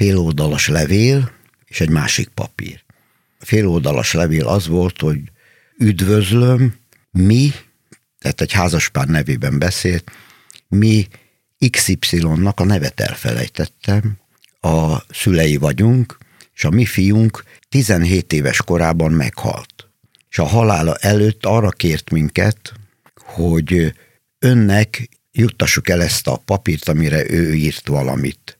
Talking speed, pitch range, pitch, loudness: 110 wpm, 80-115 Hz, 100 Hz, -16 LUFS